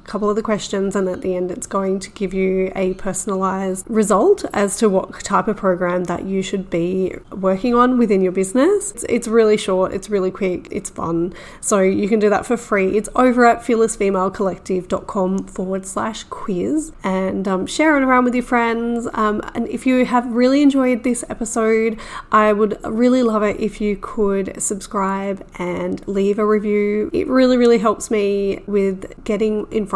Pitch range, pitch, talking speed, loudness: 190-230 Hz, 210 Hz, 185 wpm, -18 LUFS